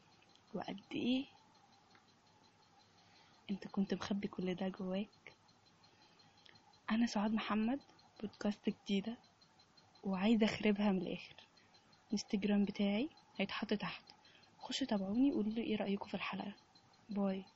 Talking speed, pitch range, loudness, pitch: 100 wpm, 200-230 Hz, -39 LUFS, 210 Hz